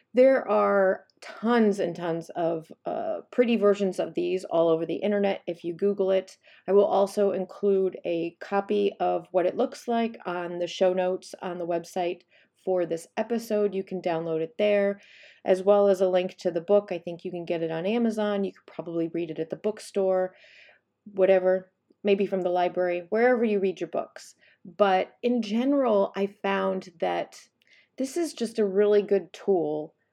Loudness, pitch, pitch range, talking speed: -26 LUFS, 195 Hz, 180-210 Hz, 185 wpm